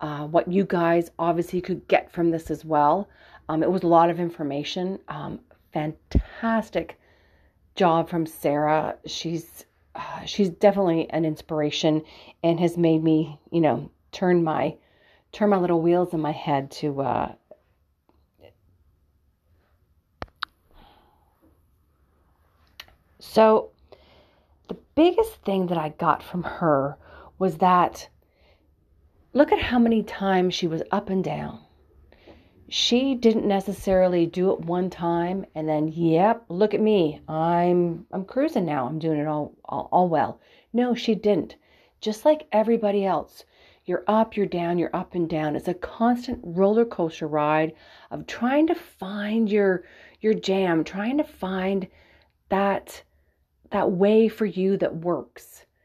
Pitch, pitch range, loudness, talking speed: 170 Hz, 150-195 Hz, -24 LUFS, 140 wpm